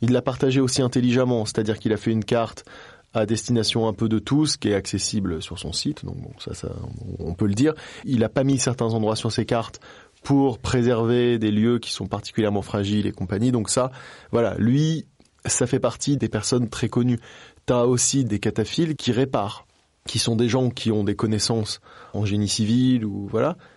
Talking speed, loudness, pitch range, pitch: 205 wpm, -23 LUFS, 105-125 Hz, 115 Hz